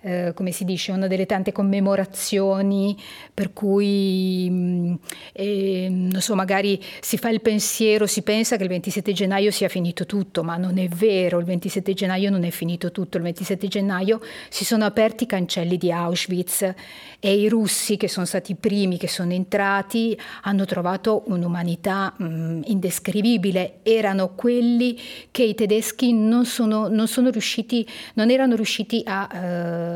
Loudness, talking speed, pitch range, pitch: -22 LUFS, 160 wpm, 185-215 Hz, 195 Hz